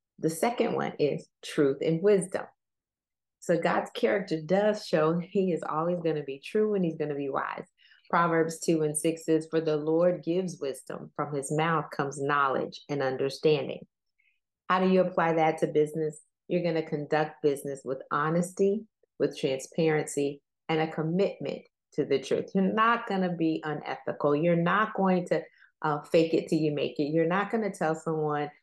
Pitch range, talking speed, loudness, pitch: 150-180 Hz, 180 wpm, -28 LUFS, 160 Hz